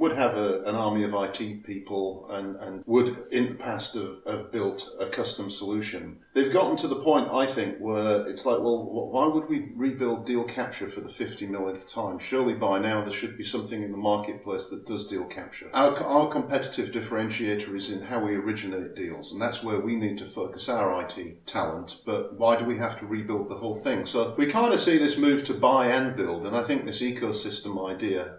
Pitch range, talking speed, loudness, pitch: 100-120 Hz, 220 wpm, -28 LUFS, 110 Hz